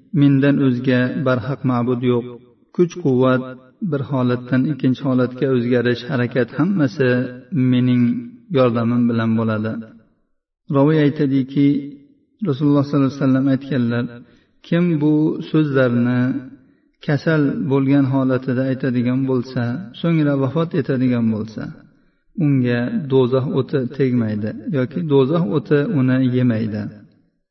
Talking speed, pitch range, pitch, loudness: 100 wpm, 125-145 Hz, 130 Hz, -18 LUFS